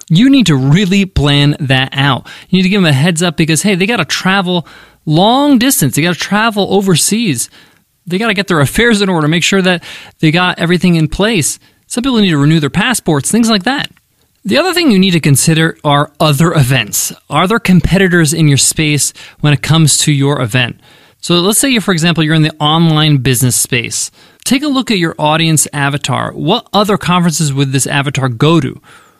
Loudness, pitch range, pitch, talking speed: -11 LUFS, 145-195 Hz, 165 Hz, 210 wpm